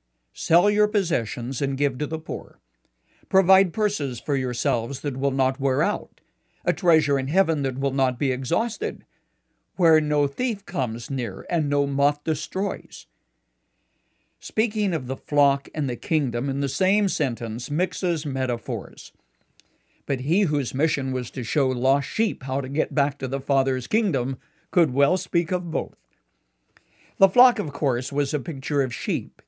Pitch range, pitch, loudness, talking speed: 130-175 Hz, 145 Hz, -24 LUFS, 160 wpm